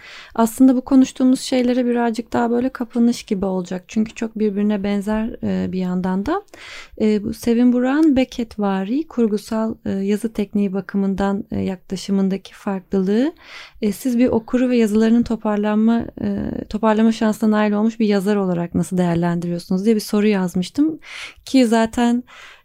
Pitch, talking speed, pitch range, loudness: 220 Hz, 125 wpm, 200-245 Hz, -19 LUFS